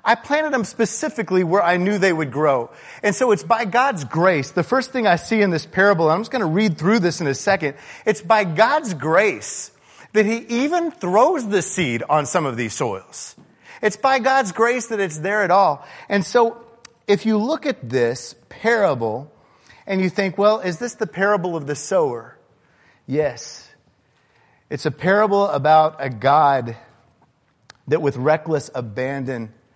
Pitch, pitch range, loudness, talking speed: 195 Hz, 150-225 Hz, -19 LUFS, 180 wpm